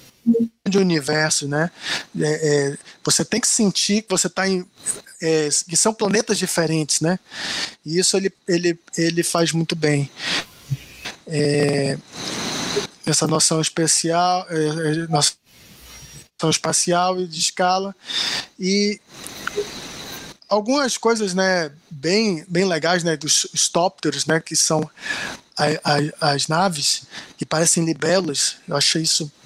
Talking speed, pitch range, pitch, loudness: 125 wpm, 155-190 Hz, 165 Hz, -20 LUFS